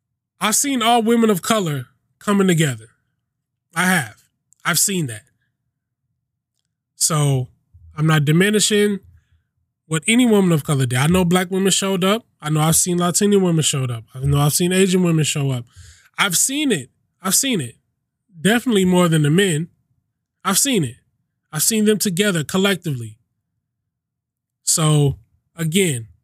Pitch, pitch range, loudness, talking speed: 150 Hz, 125-190 Hz, -17 LUFS, 150 wpm